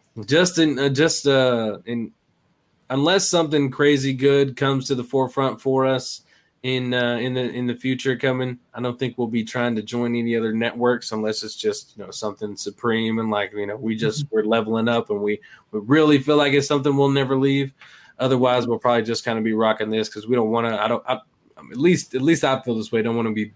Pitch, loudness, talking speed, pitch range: 125 Hz, -21 LUFS, 235 wpm, 115-140 Hz